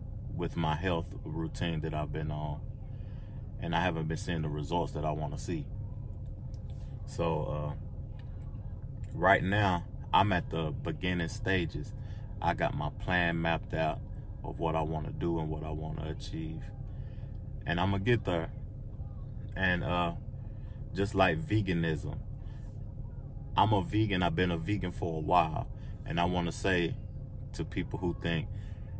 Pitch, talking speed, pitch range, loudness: 95 Hz, 155 wpm, 85-110 Hz, -33 LUFS